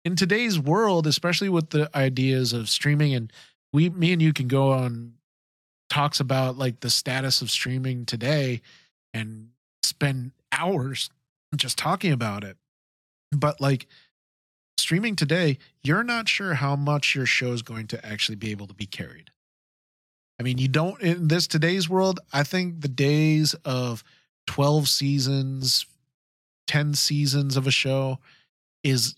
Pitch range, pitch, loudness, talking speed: 125-155 Hz, 140 Hz, -24 LUFS, 150 wpm